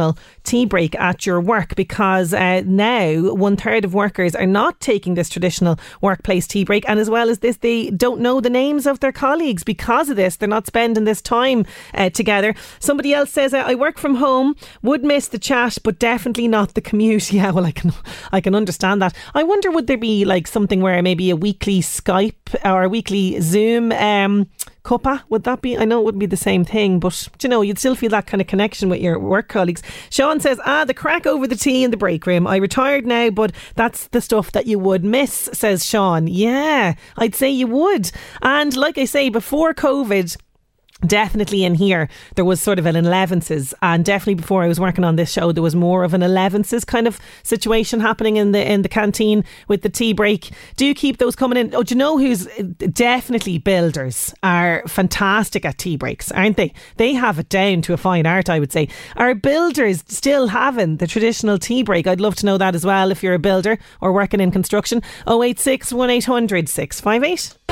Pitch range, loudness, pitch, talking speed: 185-245 Hz, -17 LUFS, 210 Hz, 220 wpm